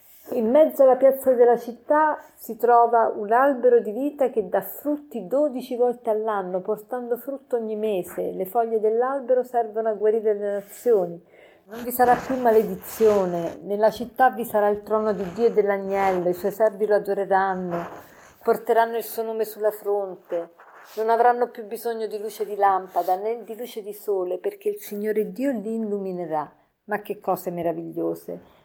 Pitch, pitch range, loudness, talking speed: 220 Hz, 200-245 Hz, -23 LUFS, 165 wpm